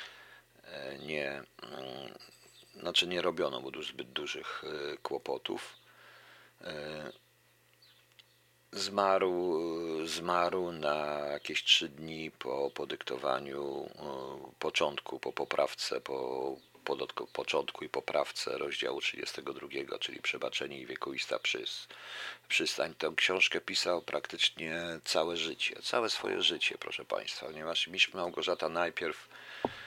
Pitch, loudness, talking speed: 370 Hz, -34 LUFS, 100 wpm